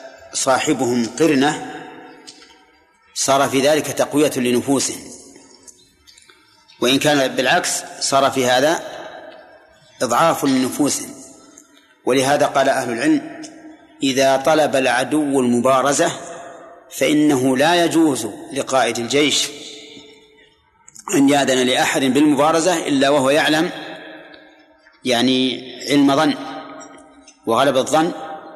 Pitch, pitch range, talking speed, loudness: 150 Hz, 135-170 Hz, 85 wpm, -17 LUFS